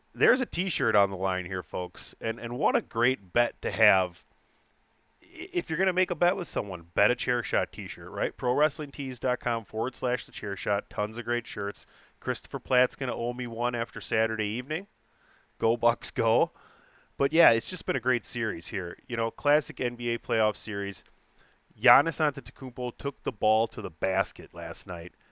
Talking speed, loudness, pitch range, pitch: 180 wpm, -28 LUFS, 110-135 Hz, 120 Hz